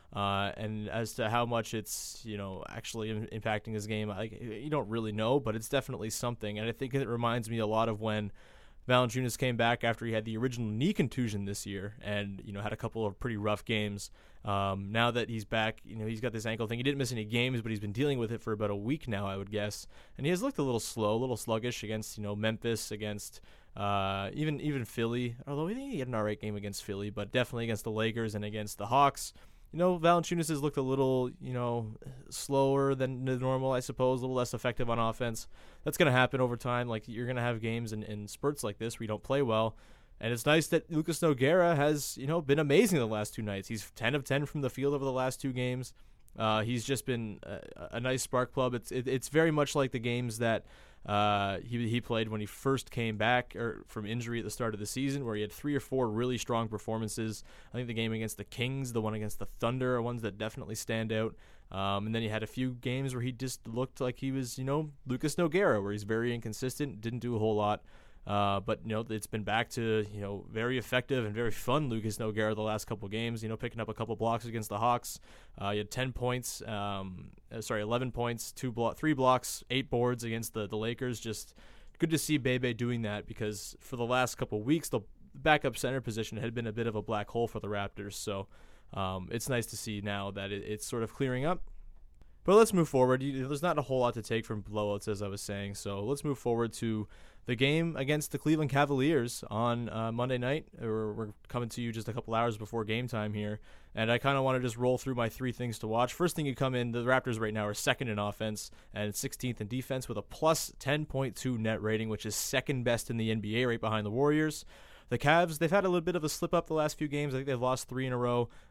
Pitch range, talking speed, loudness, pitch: 110-130 Hz, 250 wpm, -33 LUFS, 115 Hz